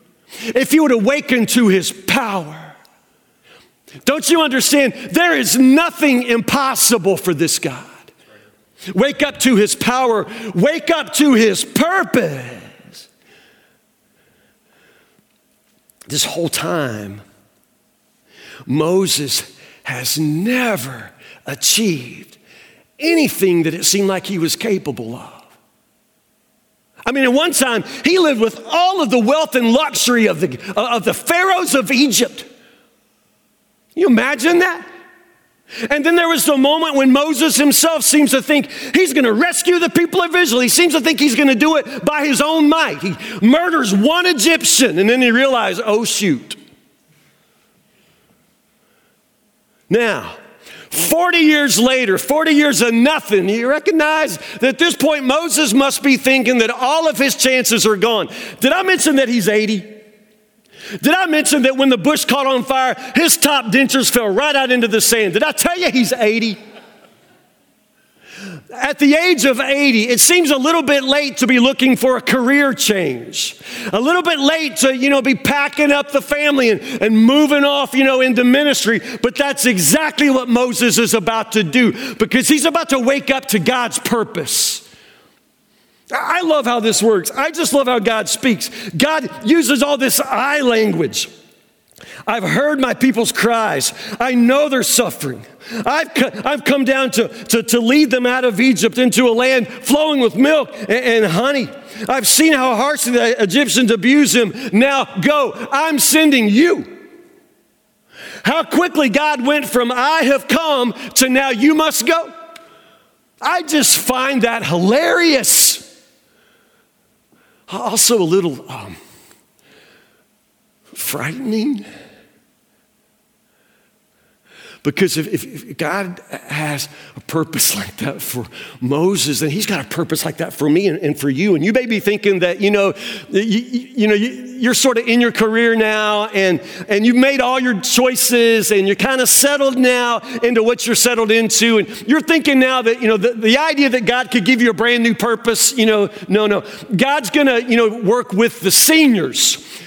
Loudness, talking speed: -14 LUFS, 160 wpm